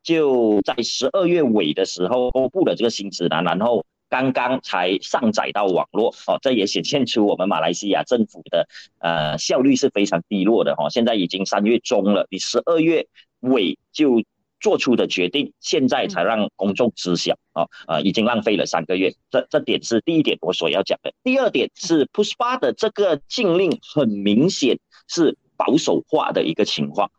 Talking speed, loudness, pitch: 285 characters per minute, -20 LUFS, 120 Hz